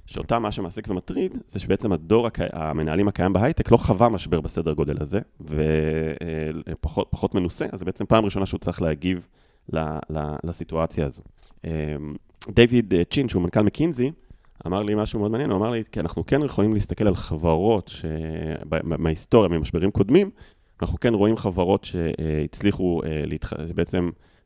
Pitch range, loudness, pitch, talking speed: 80-105 Hz, -24 LUFS, 90 Hz, 155 wpm